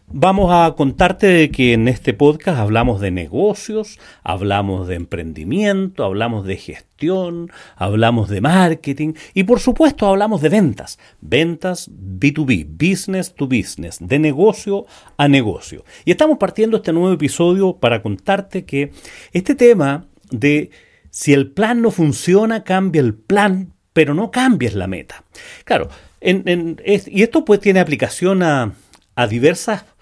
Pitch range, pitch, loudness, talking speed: 130-200 Hz, 170 Hz, -16 LUFS, 145 wpm